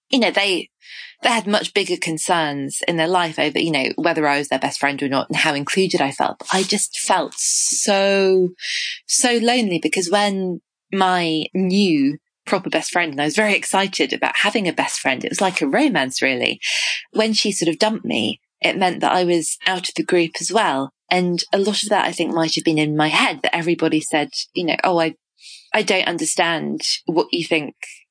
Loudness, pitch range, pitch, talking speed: -19 LUFS, 160-205 Hz, 180 Hz, 215 wpm